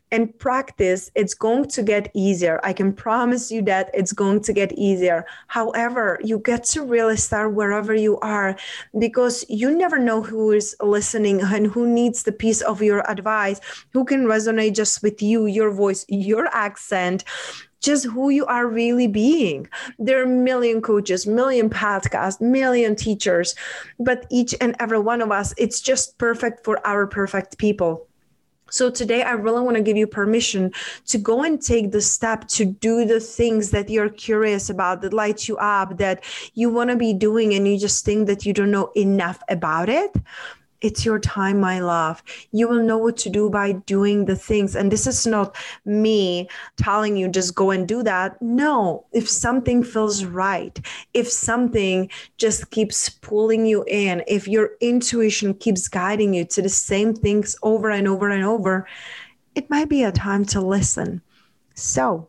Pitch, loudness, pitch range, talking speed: 215 Hz, -20 LUFS, 200-235 Hz, 180 wpm